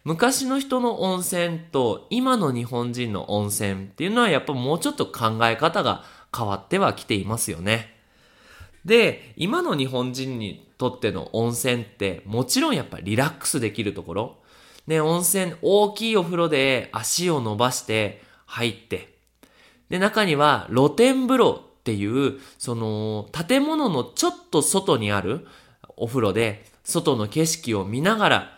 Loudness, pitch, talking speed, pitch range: -23 LUFS, 135 Hz, 290 characters per minute, 110-180 Hz